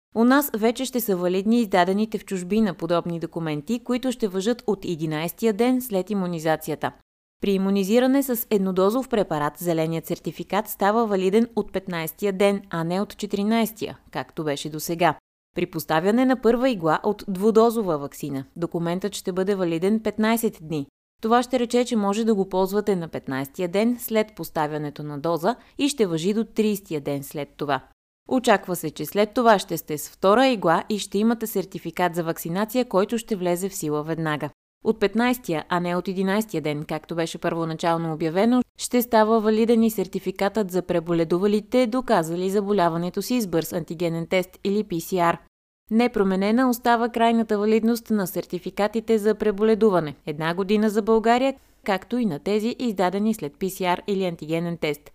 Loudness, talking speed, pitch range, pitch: -23 LUFS, 160 wpm, 170-220 Hz, 195 Hz